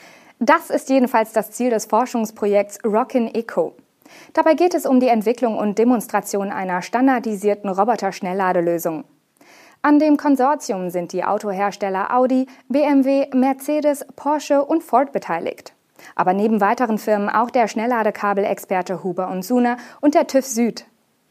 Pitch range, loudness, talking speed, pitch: 200-270 Hz, -19 LUFS, 130 wpm, 230 Hz